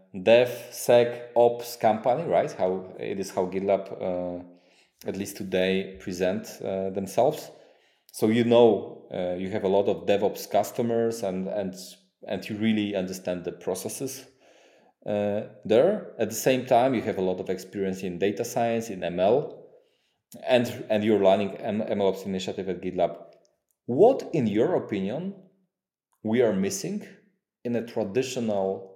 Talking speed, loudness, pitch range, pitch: 145 wpm, -26 LUFS, 95-120 Hz, 110 Hz